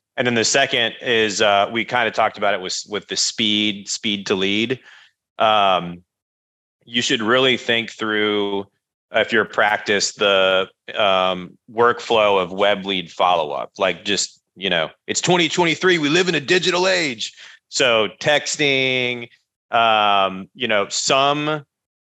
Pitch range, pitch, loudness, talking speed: 100-135 Hz, 110 Hz, -18 LUFS, 145 wpm